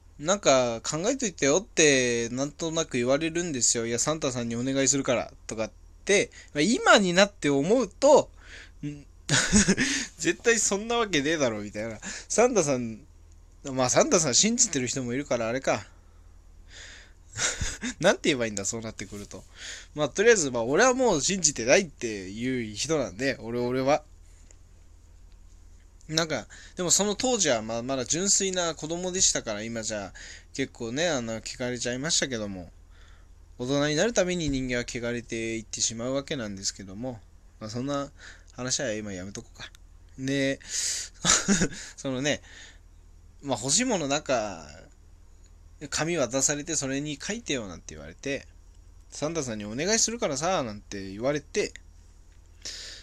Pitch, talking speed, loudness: 120 Hz, 320 characters per minute, -26 LUFS